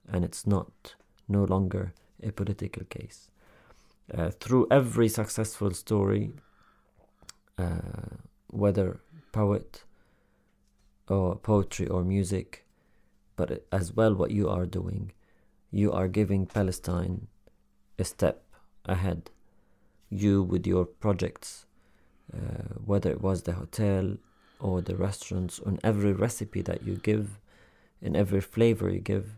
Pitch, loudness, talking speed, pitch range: 100 Hz, -29 LUFS, 120 wpm, 90-105 Hz